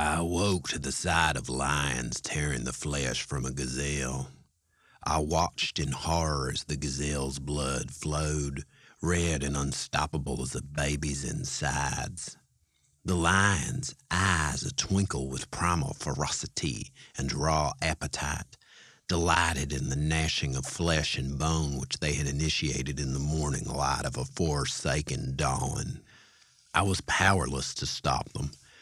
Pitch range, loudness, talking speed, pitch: 70-80 Hz, -30 LUFS, 135 wpm, 75 Hz